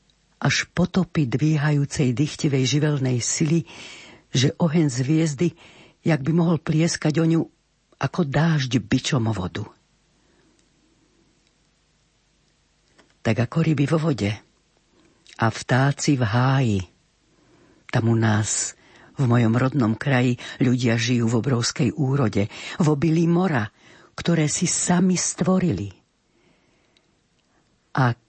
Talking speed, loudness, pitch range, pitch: 105 wpm, -22 LUFS, 120-160 Hz, 140 Hz